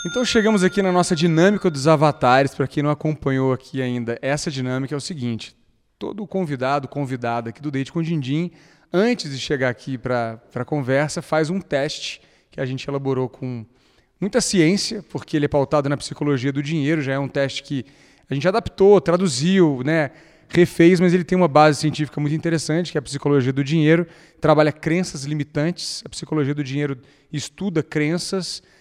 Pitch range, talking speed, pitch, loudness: 140-170 Hz, 180 wpm, 150 Hz, -20 LUFS